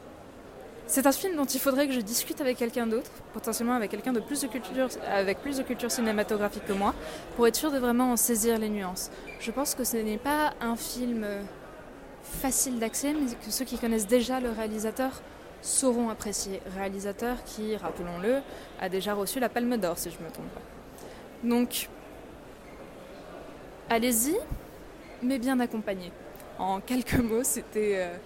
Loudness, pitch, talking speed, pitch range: -29 LUFS, 235 Hz, 170 wpm, 215-255 Hz